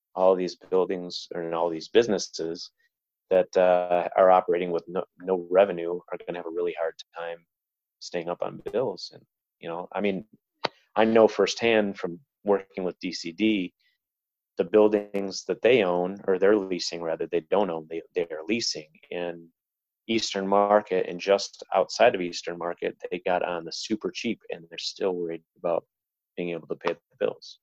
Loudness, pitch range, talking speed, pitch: -26 LUFS, 85-110 Hz, 175 wpm, 95 Hz